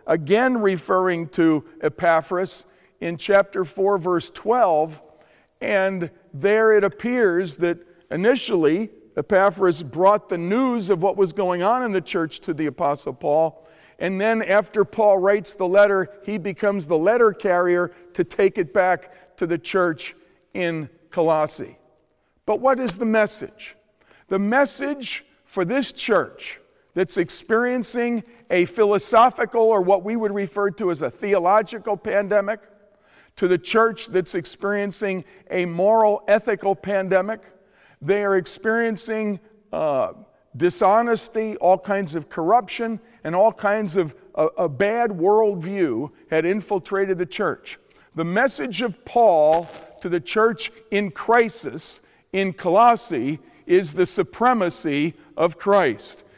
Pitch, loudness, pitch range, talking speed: 195 Hz, -21 LUFS, 175-220 Hz, 130 wpm